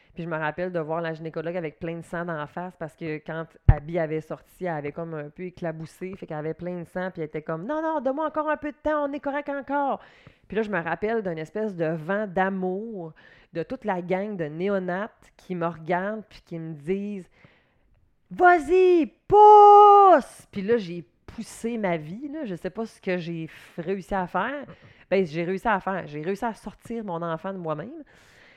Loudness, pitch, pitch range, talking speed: -24 LUFS, 185 Hz, 165-225 Hz, 220 wpm